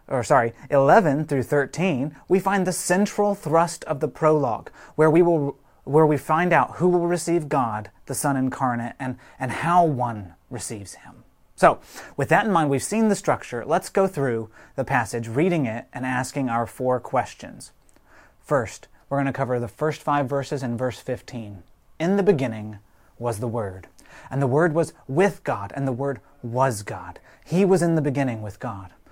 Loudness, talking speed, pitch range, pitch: -23 LUFS, 185 wpm, 120-160 Hz, 140 Hz